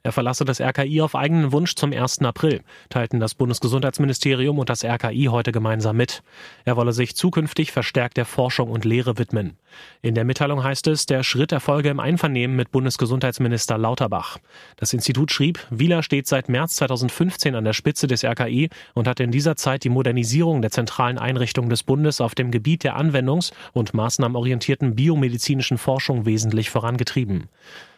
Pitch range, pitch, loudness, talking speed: 120-145 Hz, 130 Hz, -21 LUFS, 165 wpm